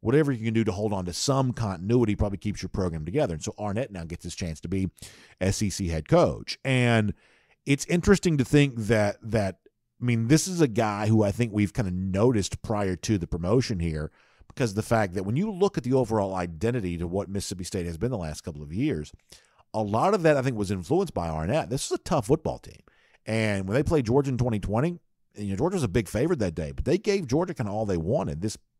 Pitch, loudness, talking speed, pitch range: 110 Hz, -26 LUFS, 245 wpm, 95-125 Hz